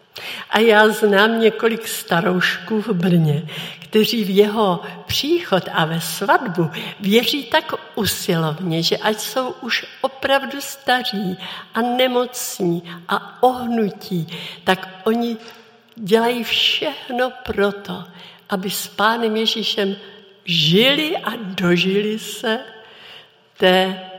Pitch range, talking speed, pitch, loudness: 185-230 Hz, 100 wpm, 210 Hz, -19 LUFS